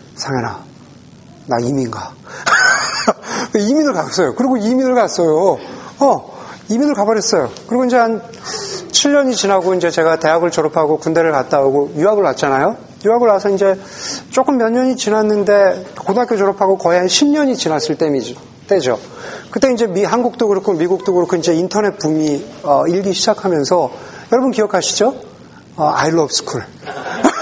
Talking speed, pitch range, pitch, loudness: 340 characters per minute, 160-230 Hz, 195 Hz, -15 LUFS